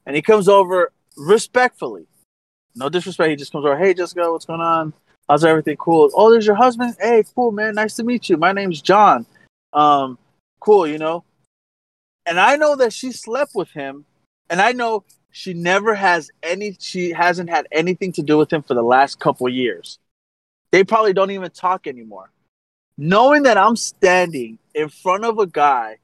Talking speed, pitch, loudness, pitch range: 185 wpm, 180 Hz, -16 LUFS, 150-215 Hz